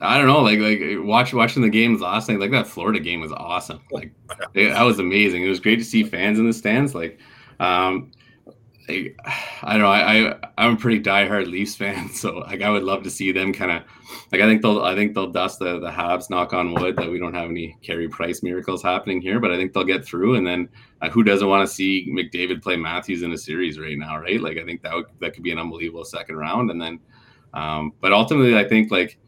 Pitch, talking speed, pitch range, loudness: 95 Hz, 250 wpm, 85-105 Hz, -20 LUFS